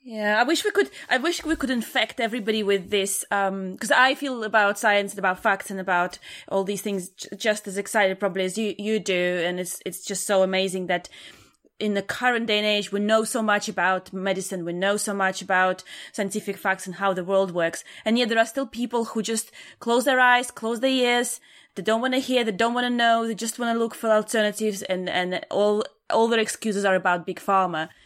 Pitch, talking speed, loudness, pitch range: 210 Hz, 230 wpm, -24 LUFS, 190-230 Hz